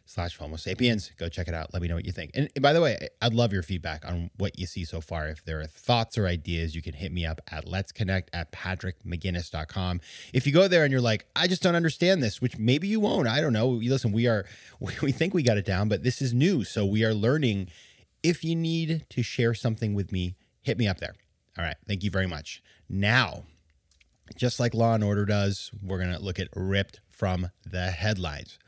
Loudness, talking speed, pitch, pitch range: -27 LUFS, 235 wpm, 100 Hz, 90-120 Hz